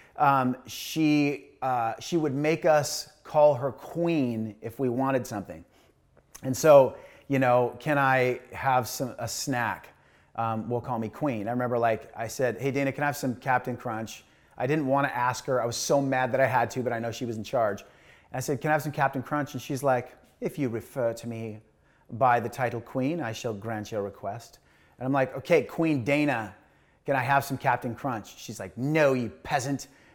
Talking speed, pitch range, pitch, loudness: 210 wpm, 115-140 Hz, 130 Hz, -27 LUFS